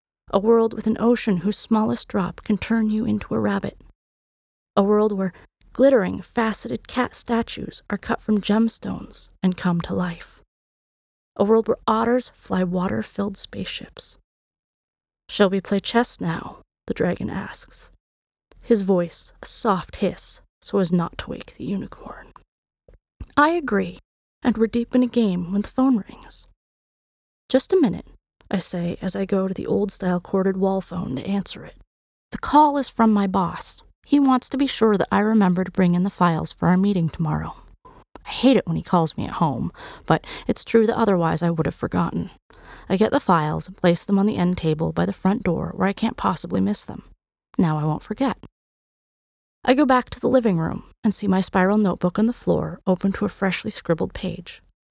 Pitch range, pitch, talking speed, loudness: 185-230 Hz, 200 Hz, 190 wpm, -22 LUFS